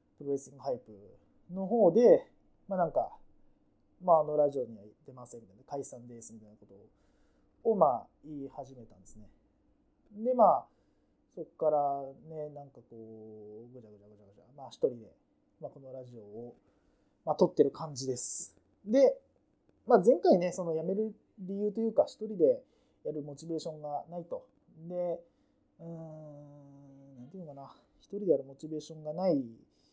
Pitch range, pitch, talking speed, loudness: 130-190 Hz, 150 Hz, 320 characters per minute, -31 LUFS